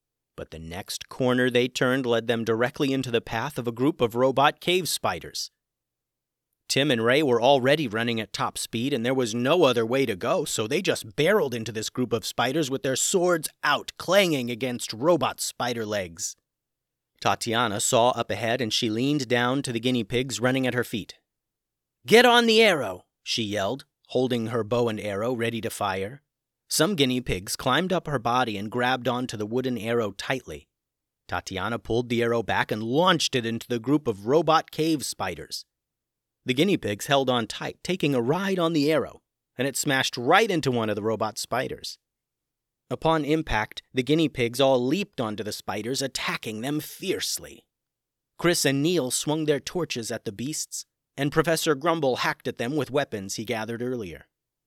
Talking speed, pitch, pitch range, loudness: 185 wpm, 125 Hz, 115-150 Hz, -25 LUFS